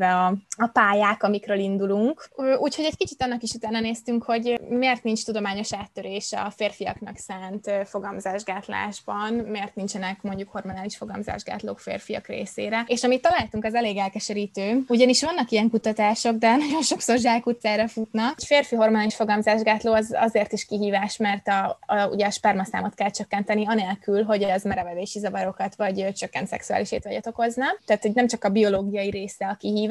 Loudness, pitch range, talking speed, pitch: -24 LUFS, 200-230 Hz, 160 wpm, 215 Hz